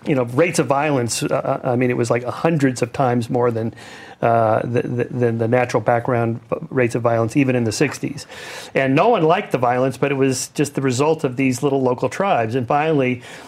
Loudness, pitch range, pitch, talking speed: -19 LUFS, 120-140 Hz, 130 Hz, 220 wpm